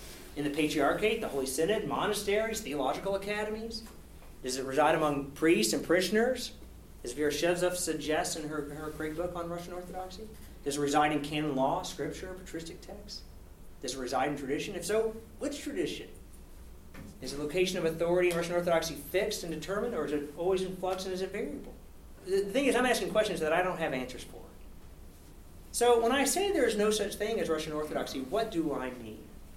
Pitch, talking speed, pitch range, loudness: 170 Hz, 190 wpm, 145-205 Hz, -31 LUFS